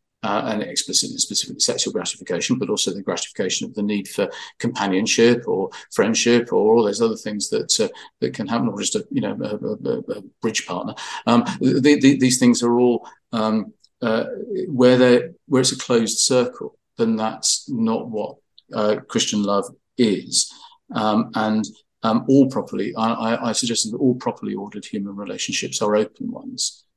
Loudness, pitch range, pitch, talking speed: -20 LUFS, 110-135 Hz, 120 Hz, 175 wpm